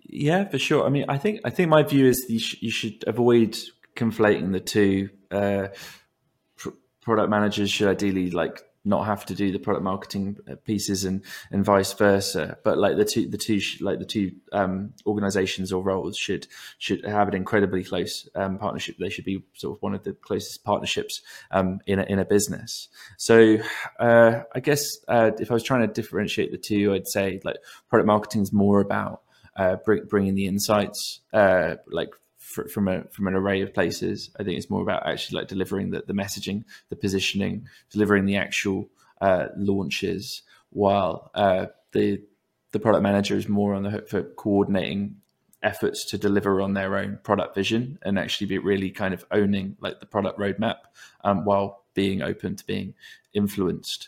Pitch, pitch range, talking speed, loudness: 100 Hz, 95-105 Hz, 190 wpm, -24 LUFS